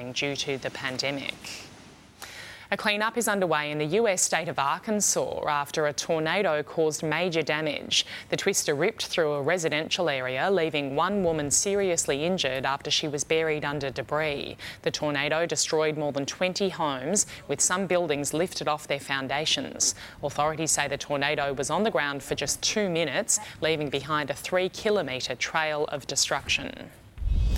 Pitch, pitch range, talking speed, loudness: 150 Hz, 140-170 Hz, 155 wpm, -26 LUFS